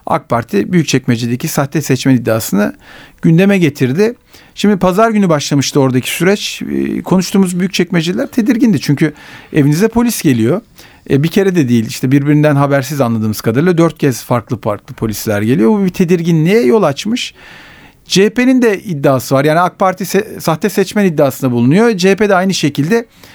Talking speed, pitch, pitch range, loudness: 150 wpm, 165 Hz, 135-195 Hz, -12 LUFS